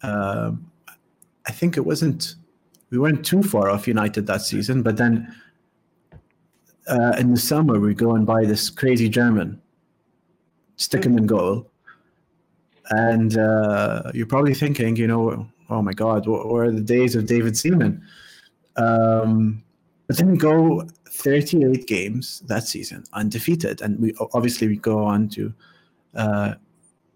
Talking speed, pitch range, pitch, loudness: 145 wpm, 110-150 Hz, 120 Hz, -20 LUFS